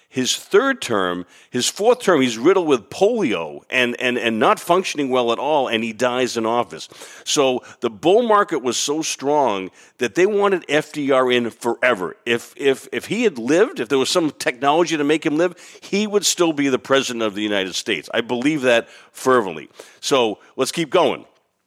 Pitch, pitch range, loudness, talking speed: 135 Hz, 120-170 Hz, -19 LUFS, 190 wpm